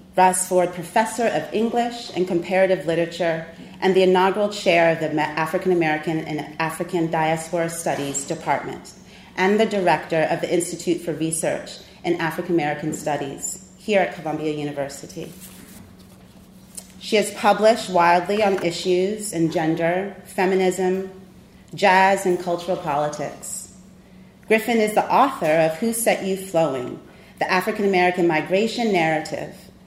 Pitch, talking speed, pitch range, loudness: 180 Hz, 130 wpm, 160-190 Hz, -21 LUFS